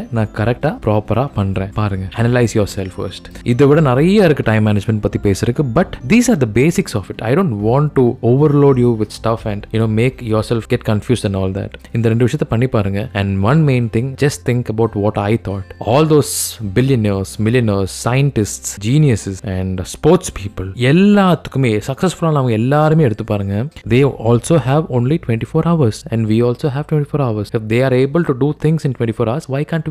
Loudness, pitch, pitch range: -15 LUFS, 120 Hz, 105-145 Hz